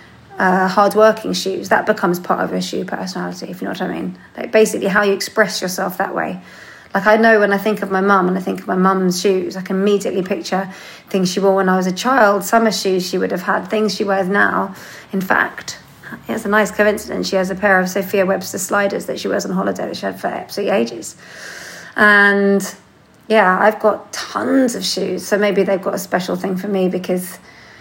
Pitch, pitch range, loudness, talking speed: 195 Hz, 185-210 Hz, -16 LUFS, 225 wpm